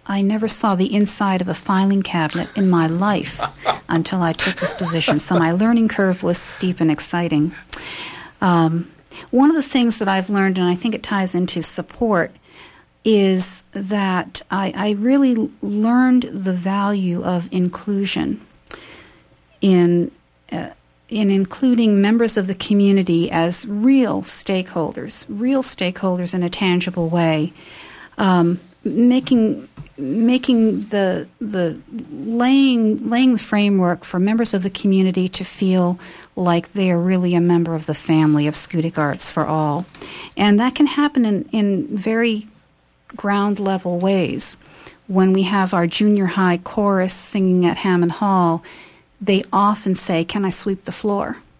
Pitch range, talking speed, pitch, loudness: 175-215 Hz, 150 wpm, 190 Hz, -18 LUFS